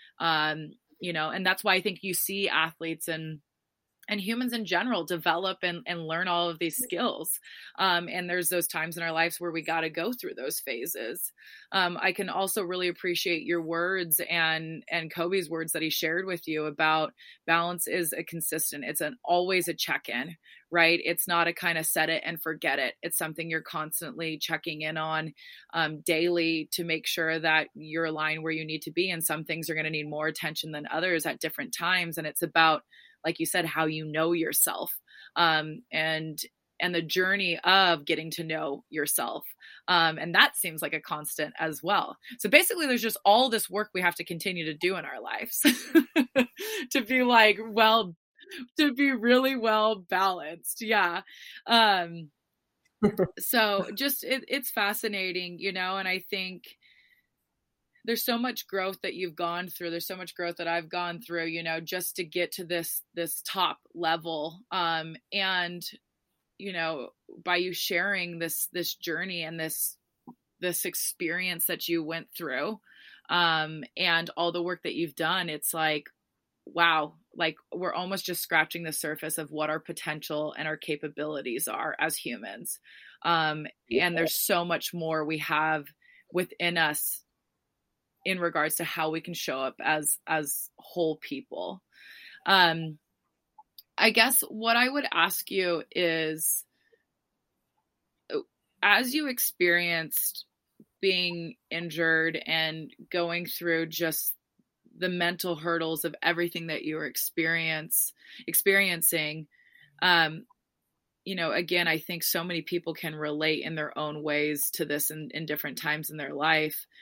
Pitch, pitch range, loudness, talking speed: 170 Hz, 160-190 Hz, -28 LUFS, 165 wpm